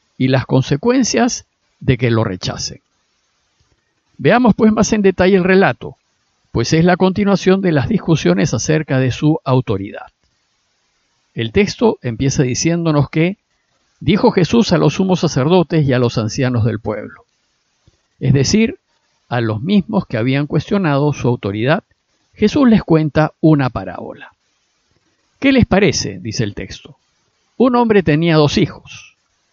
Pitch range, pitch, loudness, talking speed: 130-195 Hz, 155 Hz, -15 LUFS, 140 wpm